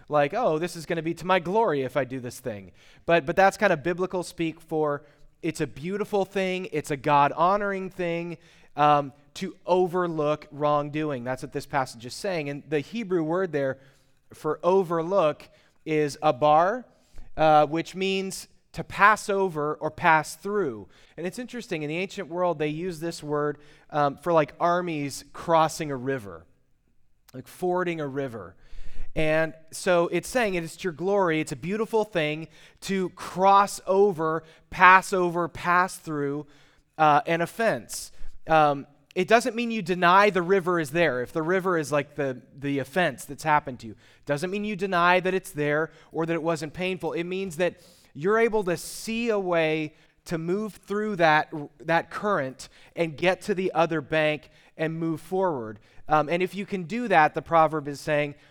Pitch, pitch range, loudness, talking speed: 160 Hz, 150-185 Hz, -25 LUFS, 180 wpm